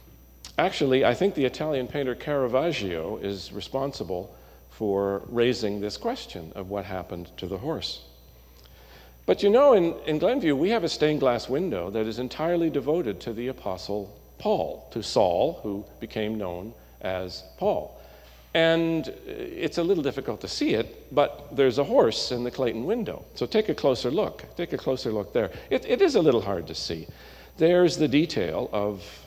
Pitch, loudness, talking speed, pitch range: 120 Hz, -26 LUFS, 170 wpm, 100-150 Hz